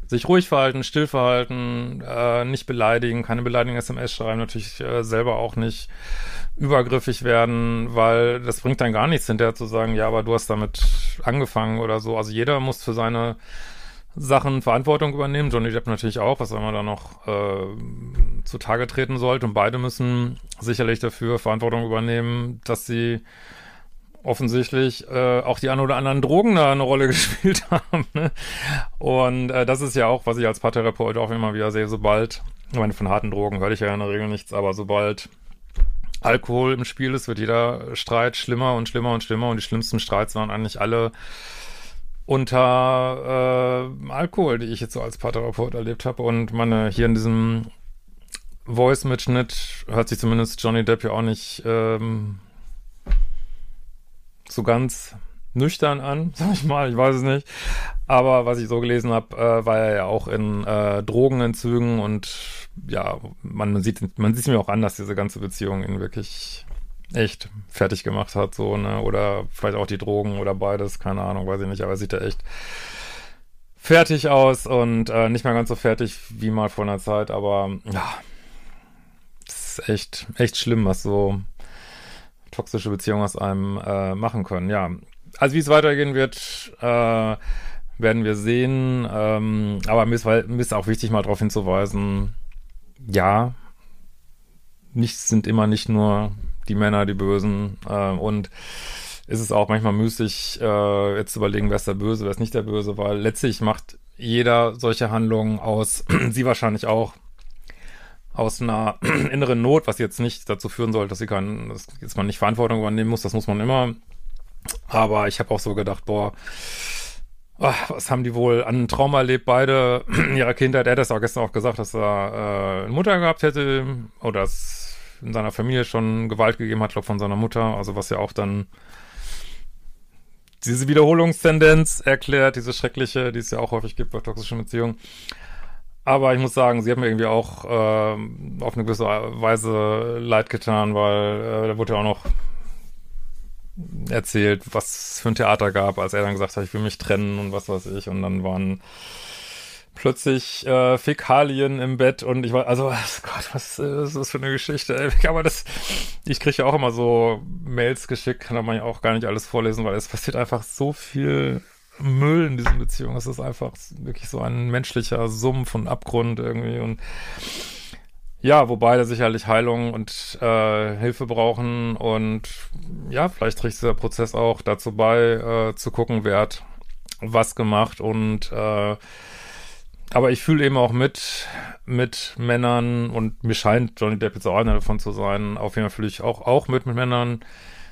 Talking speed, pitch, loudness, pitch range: 180 wpm, 115 Hz, -22 LUFS, 105-125 Hz